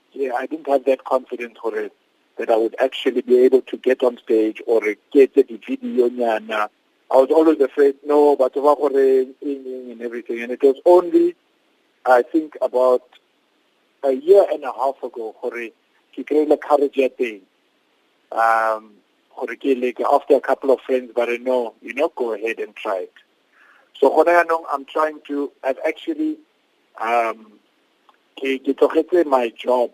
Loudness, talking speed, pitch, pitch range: -19 LUFS, 145 wpm, 140 Hz, 125-195 Hz